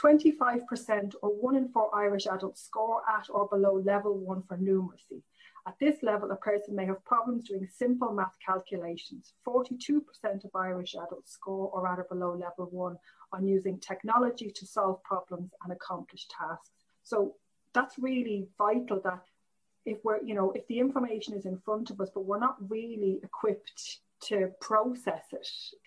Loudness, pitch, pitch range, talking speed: -32 LUFS, 205 Hz, 190-230 Hz, 170 wpm